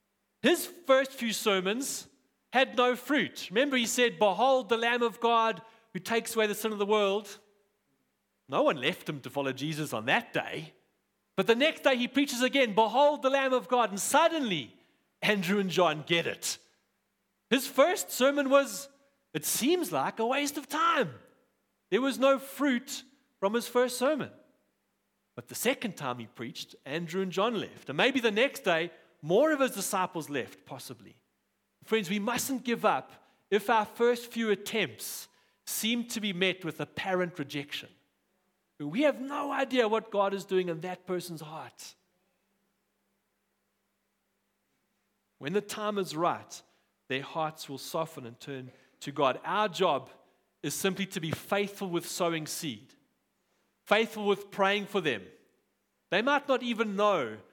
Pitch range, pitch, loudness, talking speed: 180-255 Hz, 215 Hz, -29 LUFS, 160 wpm